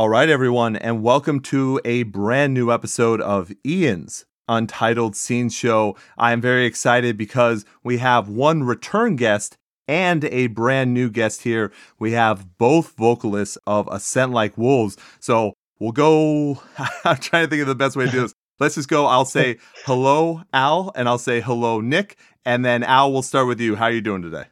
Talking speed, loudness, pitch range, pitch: 190 wpm, -19 LUFS, 115-135 Hz, 120 Hz